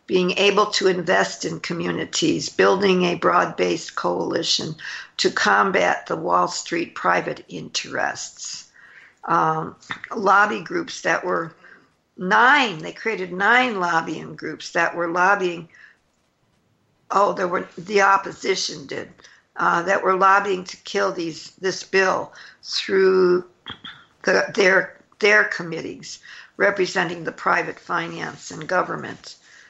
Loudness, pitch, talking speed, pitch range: -20 LUFS, 185 Hz, 115 wpm, 175-195 Hz